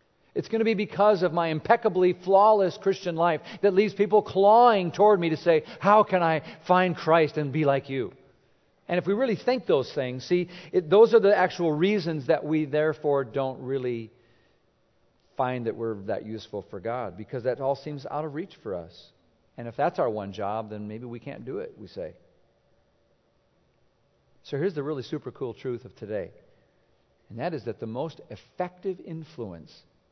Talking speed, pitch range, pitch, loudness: 185 wpm, 130-195 Hz, 160 Hz, -25 LUFS